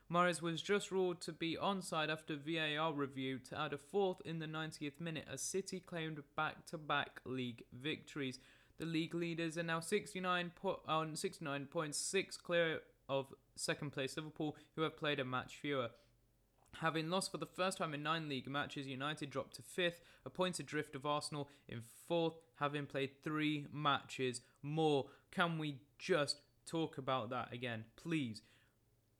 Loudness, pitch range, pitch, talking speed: -41 LUFS, 135-165 Hz, 150 Hz, 160 wpm